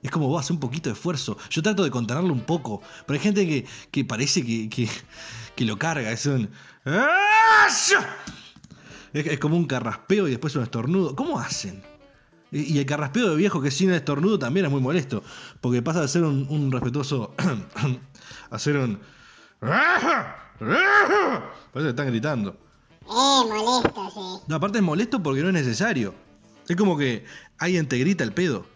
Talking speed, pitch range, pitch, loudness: 175 wpm, 125-190 Hz, 150 Hz, -23 LUFS